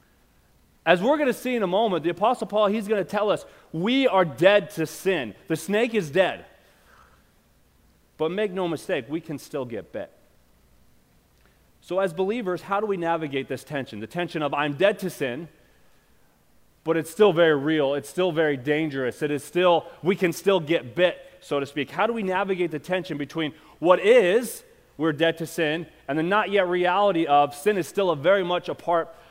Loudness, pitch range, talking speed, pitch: -24 LUFS, 150-195 Hz, 200 wpm, 170 Hz